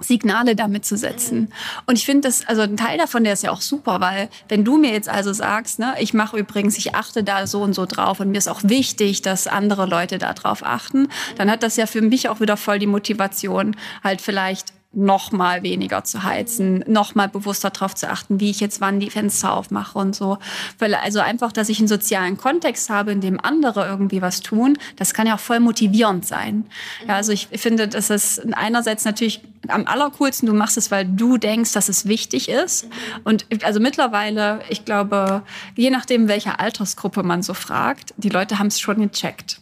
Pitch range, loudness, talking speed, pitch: 200-230 Hz, -19 LUFS, 210 wpm, 210 Hz